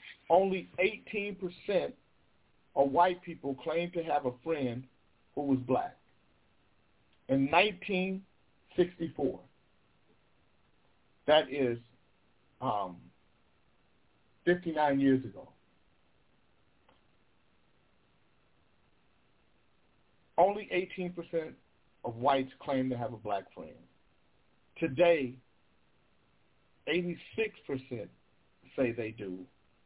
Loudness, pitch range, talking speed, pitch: -32 LUFS, 125-175 Hz, 80 wpm, 140 Hz